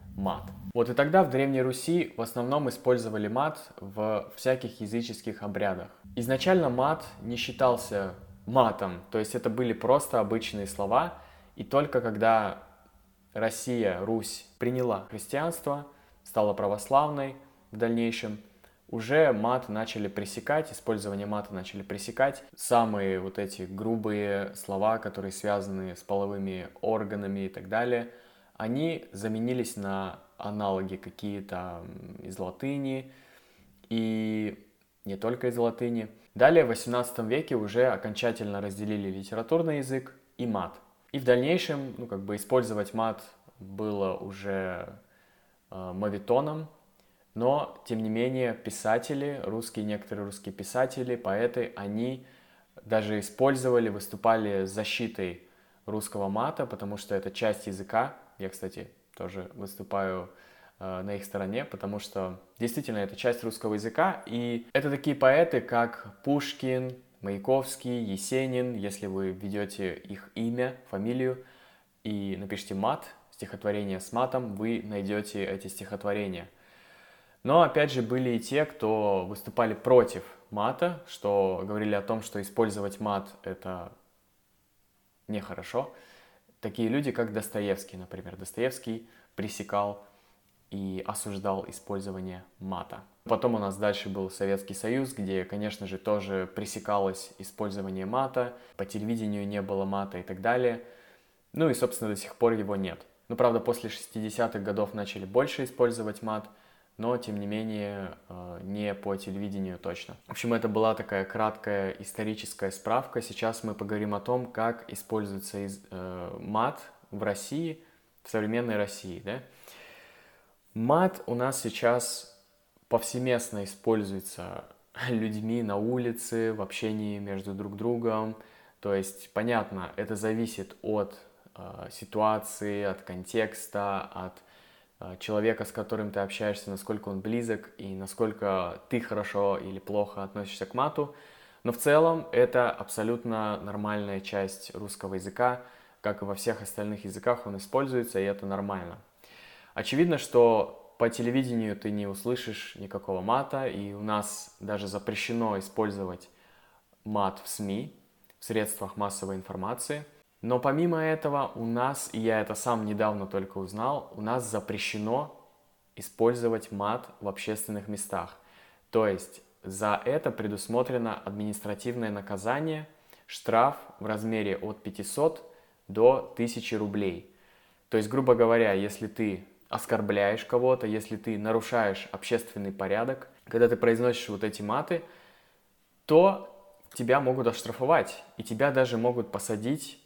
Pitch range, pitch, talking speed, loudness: 100-120 Hz, 105 Hz, 125 wpm, -30 LUFS